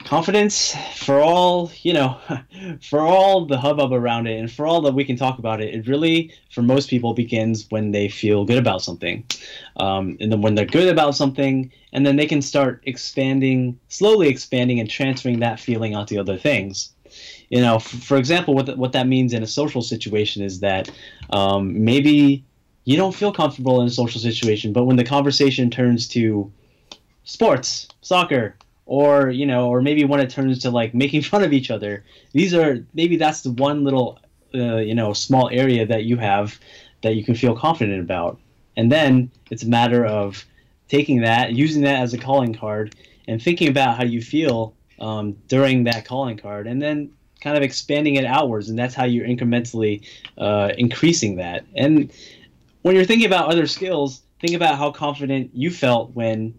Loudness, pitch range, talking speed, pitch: -19 LUFS, 115-145 Hz, 190 wpm, 125 Hz